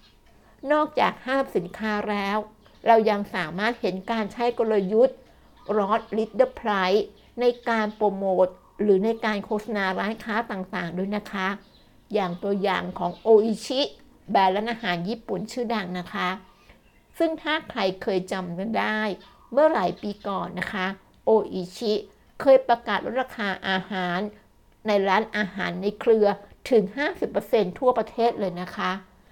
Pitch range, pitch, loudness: 190-230 Hz, 210 Hz, -25 LUFS